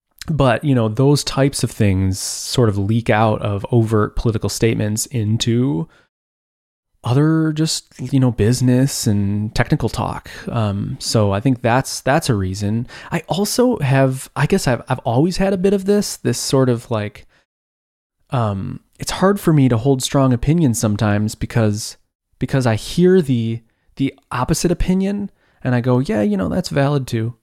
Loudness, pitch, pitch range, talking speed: -18 LUFS, 125 Hz, 110-145 Hz, 165 wpm